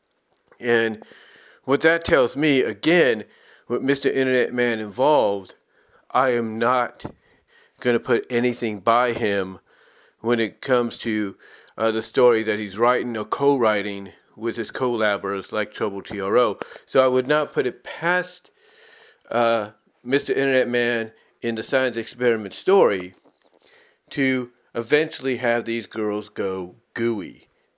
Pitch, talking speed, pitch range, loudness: 120 Hz, 130 wpm, 110-130 Hz, -22 LUFS